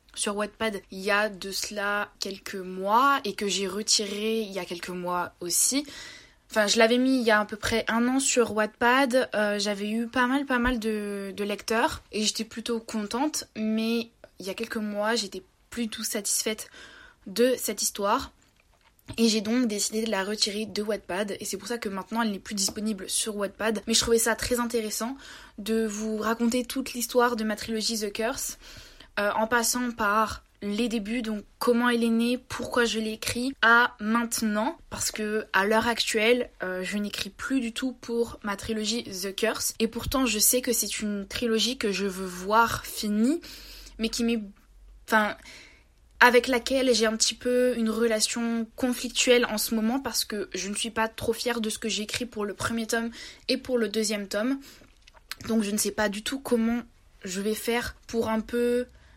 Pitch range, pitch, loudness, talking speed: 210-240 Hz, 225 Hz, -26 LUFS, 195 wpm